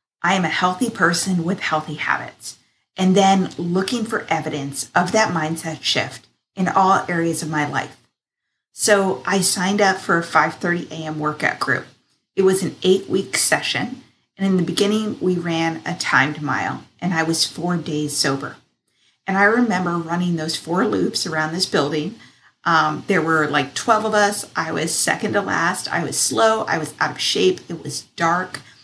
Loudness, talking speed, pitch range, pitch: -20 LUFS, 180 wpm, 155-195 Hz, 175 Hz